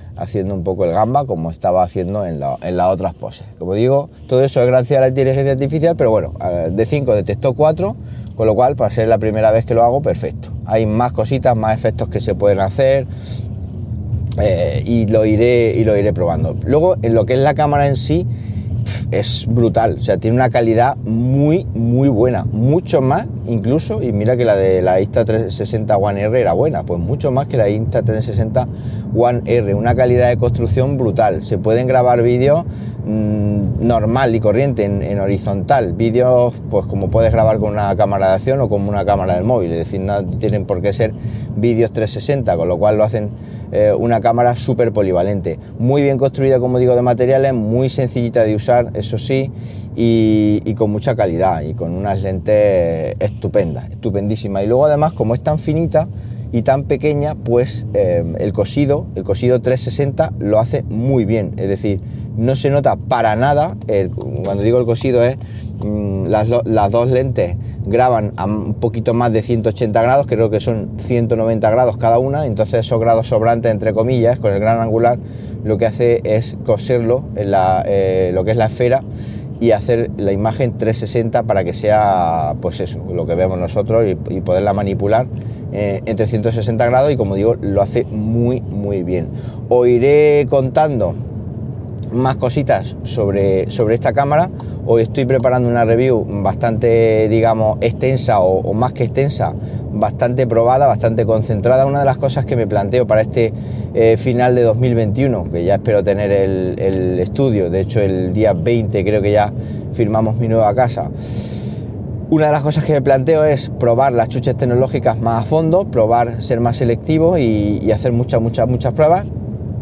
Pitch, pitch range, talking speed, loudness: 115 Hz, 105-125 Hz, 185 wpm, -15 LUFS